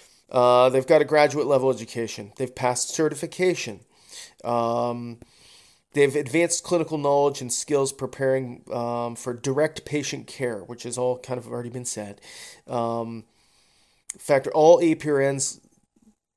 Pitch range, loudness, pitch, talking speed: 120-150 Hz, -23 LUFS, 130 Hz, 130 wpm